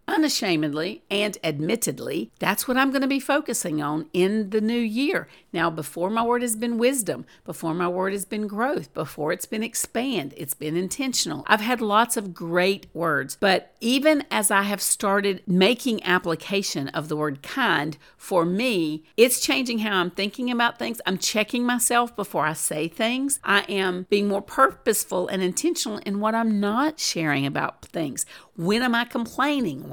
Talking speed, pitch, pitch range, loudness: 175 wpm, 210 Hz, 180-245 Hz, -24 LUFS